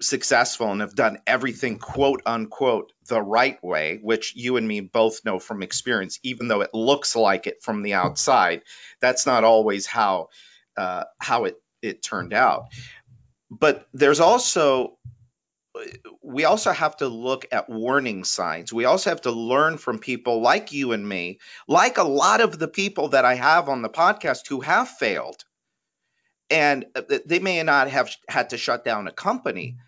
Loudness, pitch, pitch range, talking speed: -22 LUFS, 125 Hz, 110-155 Hz, 170 wpm